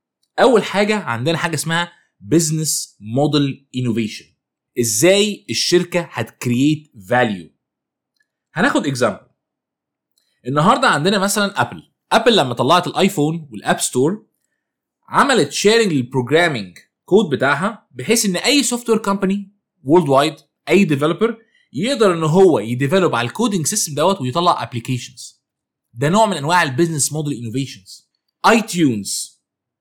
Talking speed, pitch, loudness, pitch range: 115 wpm, 160 Hz, -17 LUFS, 130-195 Hz